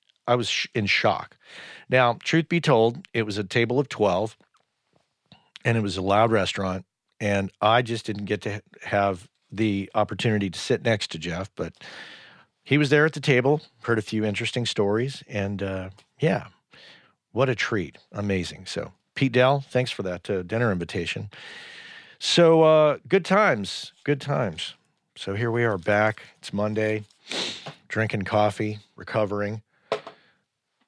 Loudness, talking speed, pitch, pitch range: -24 LUFS, 155 wpm, 110 Hz, 100-135 Hz